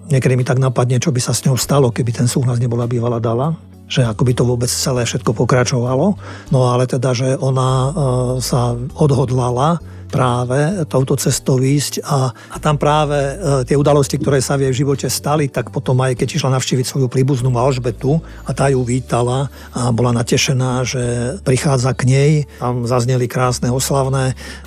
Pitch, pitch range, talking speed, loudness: 130 Hz, 125-140 Hz, 175 wpm, -16 LUFS